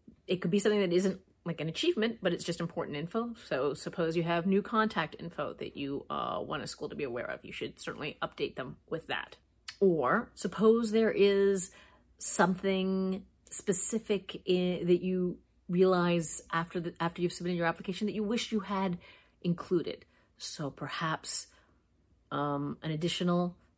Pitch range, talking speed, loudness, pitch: 170-200 Hz, 165 wpm, -32 LUFS, 180 Hz